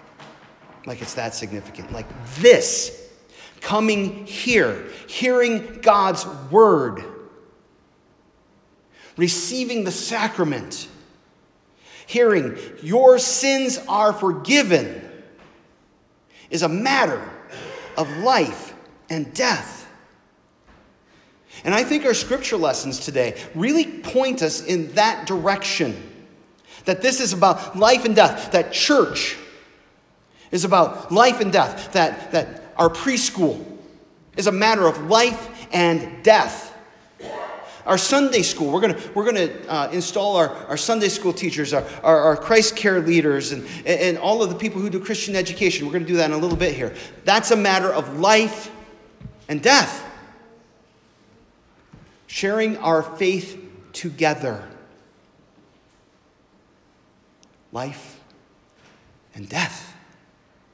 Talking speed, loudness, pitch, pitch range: 115 wpm, -19 LUFS, 195 Hz, 170-230 Hz